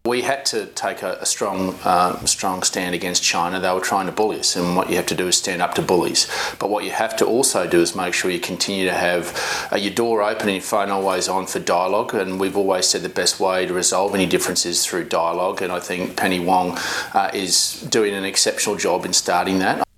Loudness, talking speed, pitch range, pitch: -19 LUFS, 240 wpm, 90-100 Hz, 95 Hz